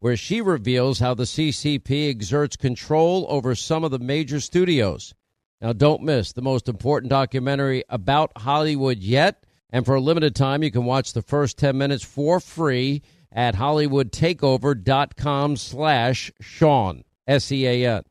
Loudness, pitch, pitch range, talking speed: -21 LUFS, 140 Hz, 125-150 Hz, 145 wpm